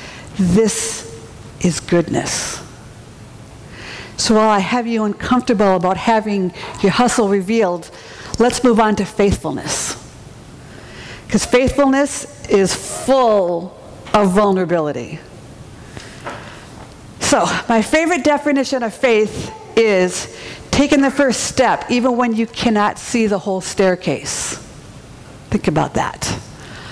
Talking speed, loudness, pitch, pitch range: 105 wpm, -16 LUFS, 210 Hz, 180-240 Hz